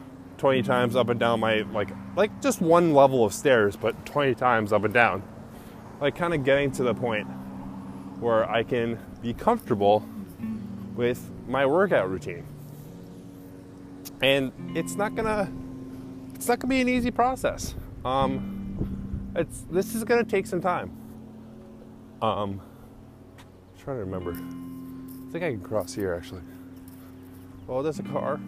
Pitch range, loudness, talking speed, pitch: 95-140 Hz, -26 LUFS, 155 wpm, 115 Hz